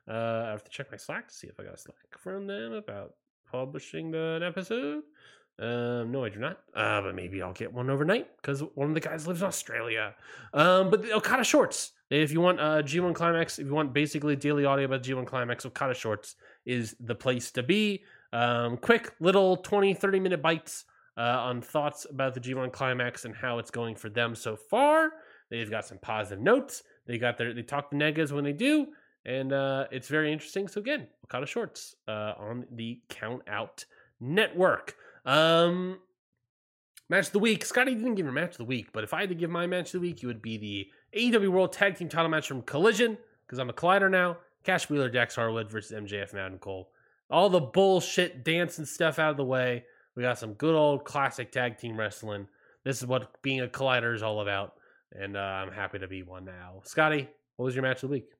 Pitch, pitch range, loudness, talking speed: 140 Hz, 120-175 Hz, -29 LUFS, 215 wpm